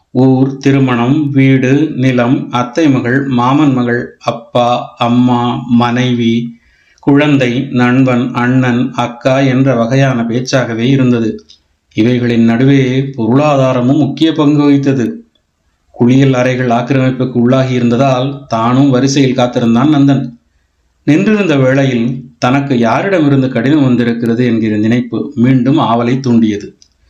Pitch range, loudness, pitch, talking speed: 120-135 Hz, -11 LUFS, 125 Hz, 95 wpm